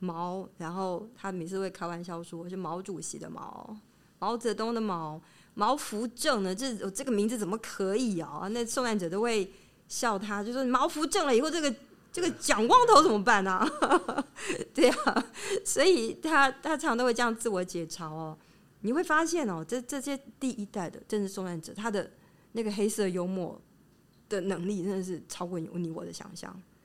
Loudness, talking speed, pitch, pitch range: -30 LUFS, 275 characters per minute, 210 Hz, 180-255 Hz